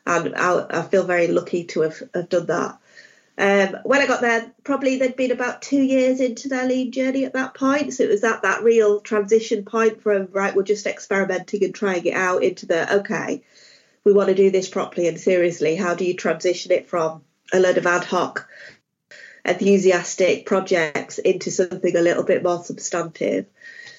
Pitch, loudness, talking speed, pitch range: 195 Hz, -20 LUFS, 190 wpm, 180-235 Hz